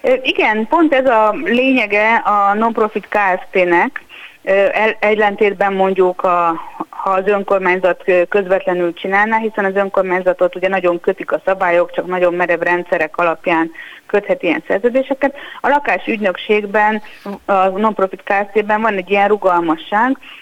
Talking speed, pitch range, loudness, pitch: 120 wpm, 180-215 Hz, -15 LUFS, 200 Hz